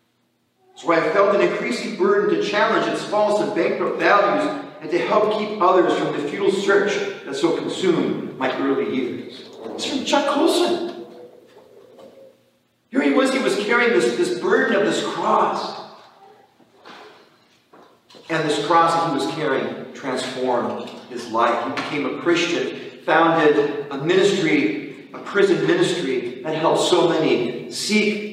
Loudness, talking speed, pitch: -20 LUFS, 145 wpm, 210 Hz